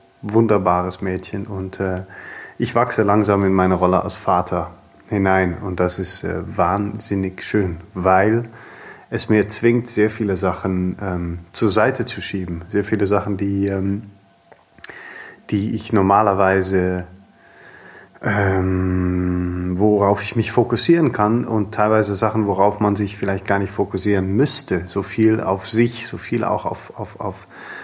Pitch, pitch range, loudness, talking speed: 100 Hz, 95-105 Hz, -19 LUFS, 140 wpm